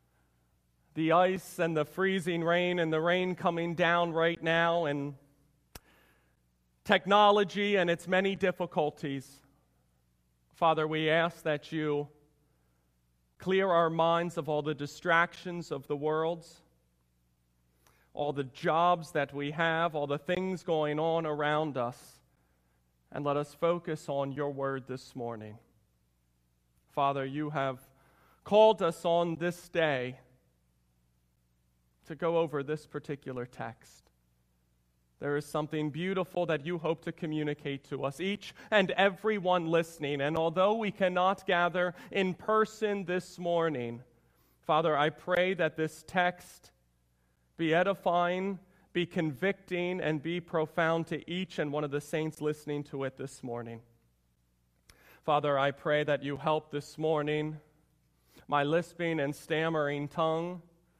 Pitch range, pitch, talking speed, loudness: 130-170 Hz, 155 Hz, 130 wpm, -31 LUFS